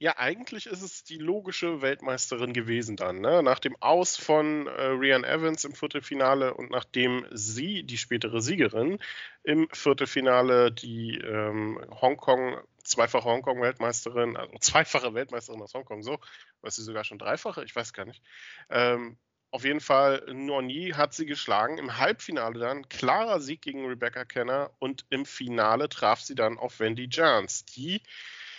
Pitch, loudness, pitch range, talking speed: 130 Hz, -28 LUFS, 120-145 Hz, 155 wpm